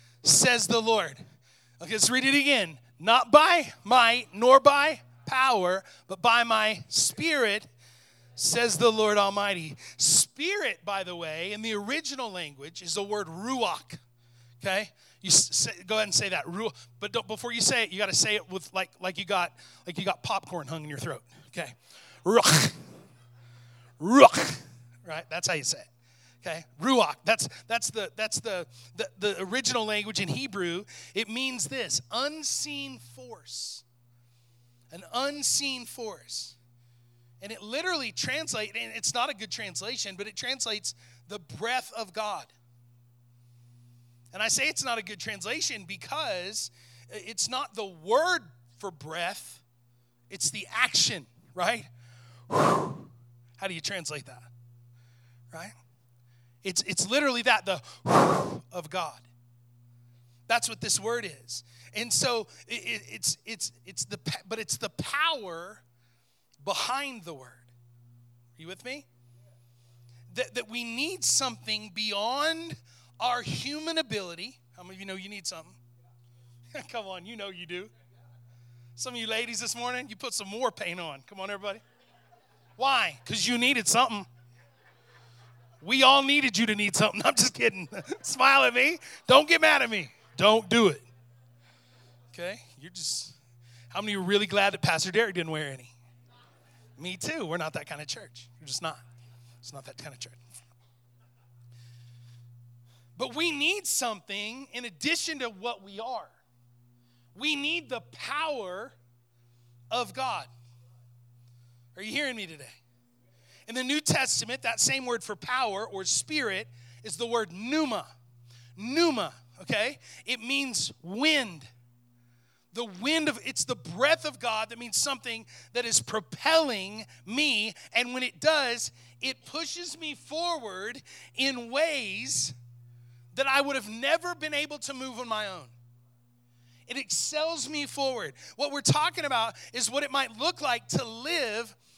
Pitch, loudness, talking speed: 185 Hz, -27 LUFS, 150 wpm